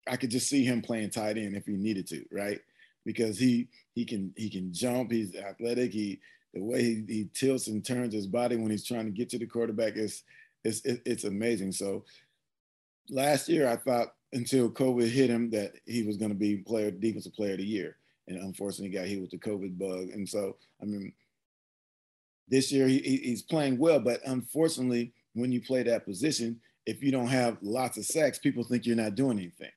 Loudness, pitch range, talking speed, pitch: -31 LUFS, 105-125 Hz, 210 wpm, 115 Hz